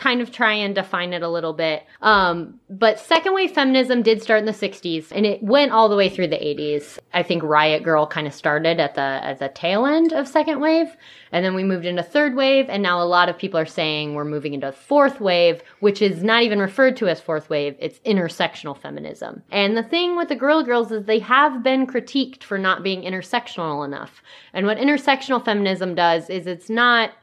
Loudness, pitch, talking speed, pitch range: -19 LUFS, 200 Hz, 225 wpm, 170-245 Hz